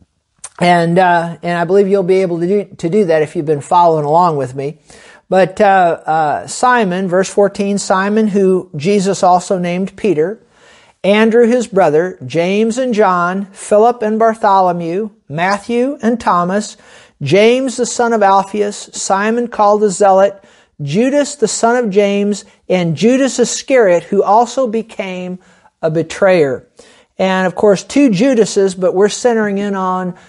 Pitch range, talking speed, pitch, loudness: 180-220 Hz, 150 wpm, 200 Hz, -13 LUFS